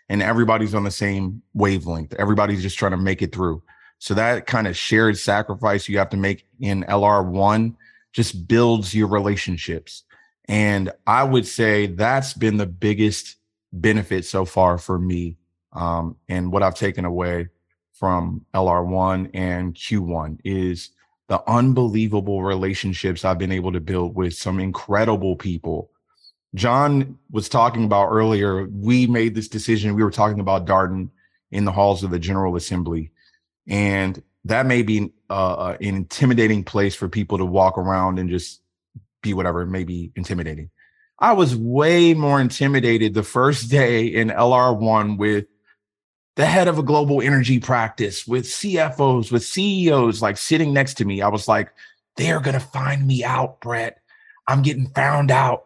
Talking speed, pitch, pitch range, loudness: 160 wpm, 105 Hz, 95-115 Hz, -20 LUFS